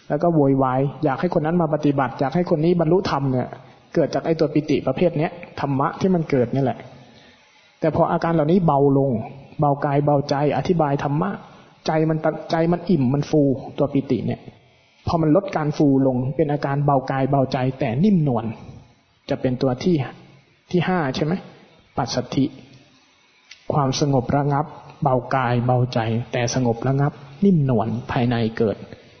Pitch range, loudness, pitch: 130-160 Hz, -21 LUFS, 145 Hz